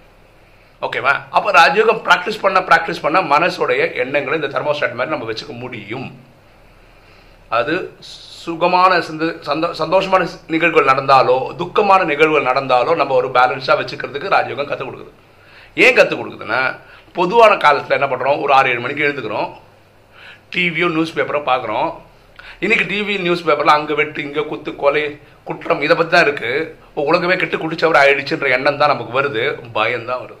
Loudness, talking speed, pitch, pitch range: -15 LUFS, 140 wpm, 160 Hz, 145-185 Hz